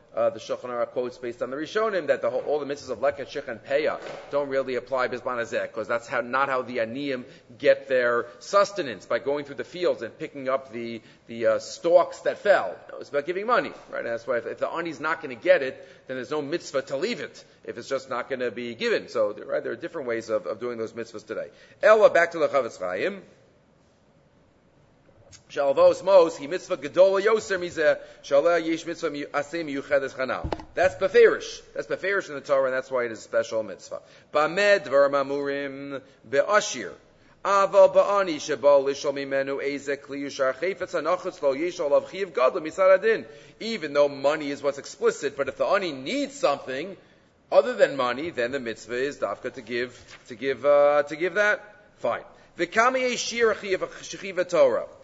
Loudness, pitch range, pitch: -25 LUFS, 135-195 Hz, 145 Hz